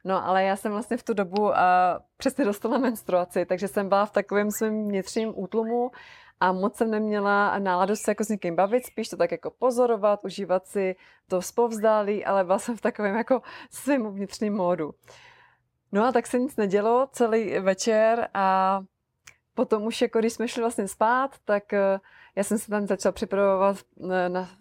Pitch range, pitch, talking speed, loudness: 195-230 Hz, 210 Hz, 180 wpm, -25 LUFS